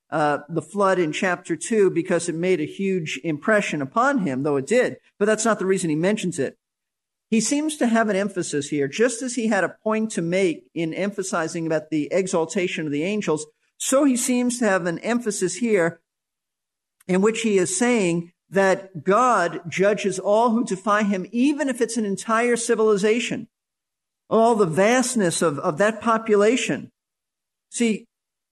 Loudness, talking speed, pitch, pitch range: -22 LUFS, 175 wpm, 195 Hz, 170-225 Hz